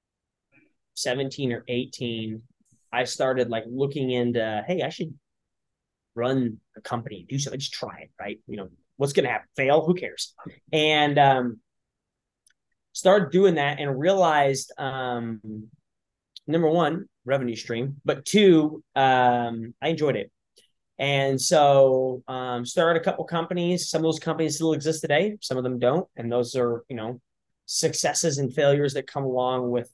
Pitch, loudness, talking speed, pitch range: 135 Hz, -24 LUFS, 155 wpm, 120-155 Hz